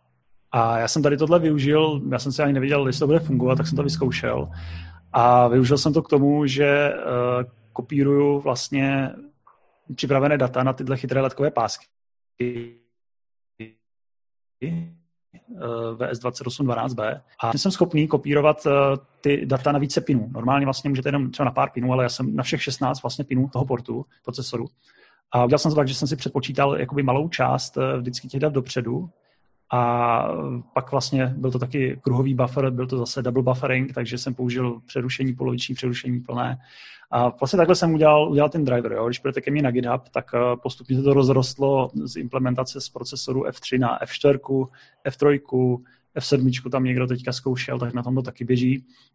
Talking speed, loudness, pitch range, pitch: 175 wpm, -22 LUFS, 125-145 Hz, 130 Hz